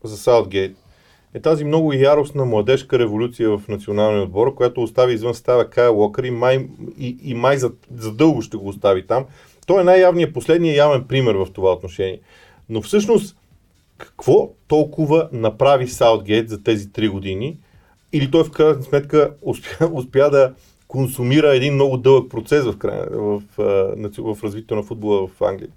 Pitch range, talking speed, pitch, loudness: 110-150 Hz, 160 wpm, 125 Hz, -17 LUFS